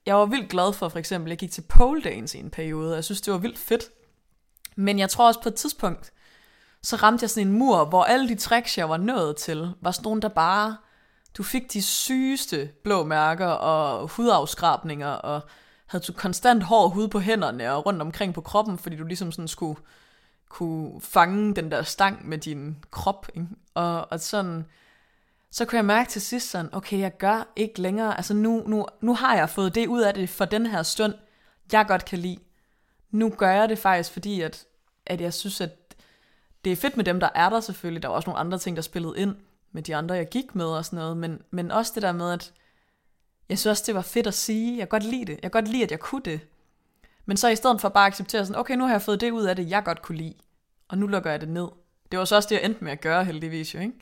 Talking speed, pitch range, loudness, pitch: 250 wpm, 170-220 Hz, -25 LUFS, 195 Hz